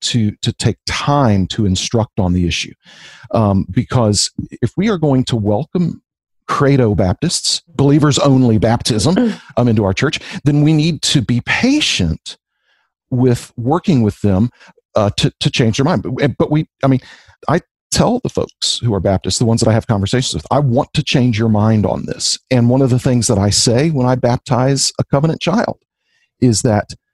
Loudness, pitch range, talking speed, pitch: -15 LUFS, 110-145 Hz, 190 wpm, 125 Hz